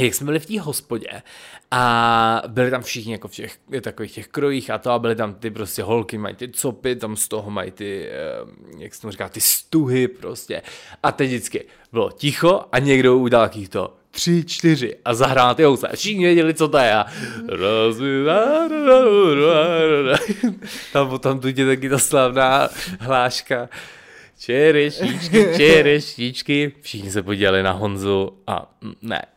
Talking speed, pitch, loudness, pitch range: 160 wpm, 130 Hz, -18 LUFS, 115-155 Hz